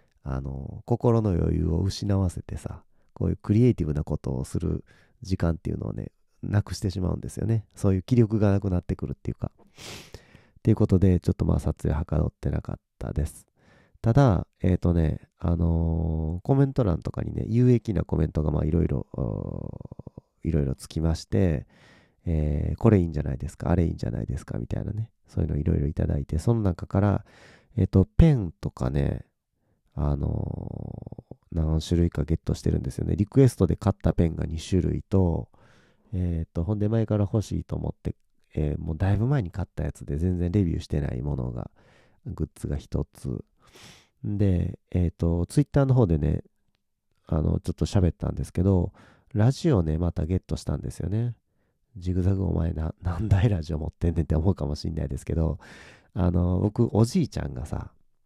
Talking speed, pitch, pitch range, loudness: 370 characters per minute, 90 Hz, 80-105 Hz, -26 LUFS